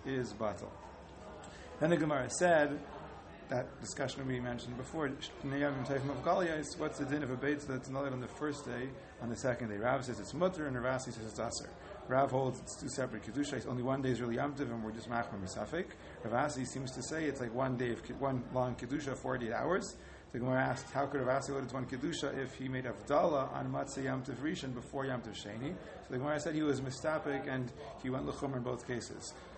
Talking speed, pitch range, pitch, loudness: 215 wpm, 125-140 Hz, 130 Hz, -37 LUFS